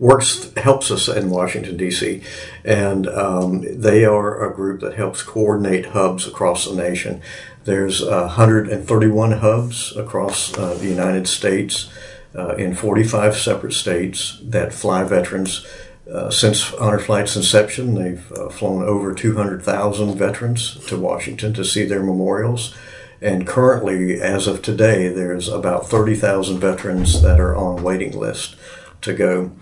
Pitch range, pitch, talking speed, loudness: 90-110 Hz, 100 Hz, 140 wpm, -18 LUFS